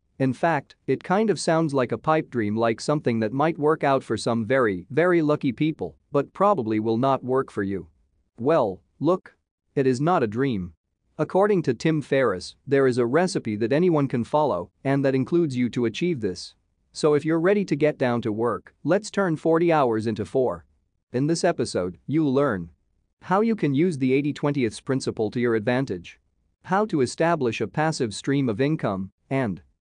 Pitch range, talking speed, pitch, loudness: 115-160 Hz, 190 wpm, 135 Hz, -24 LUFS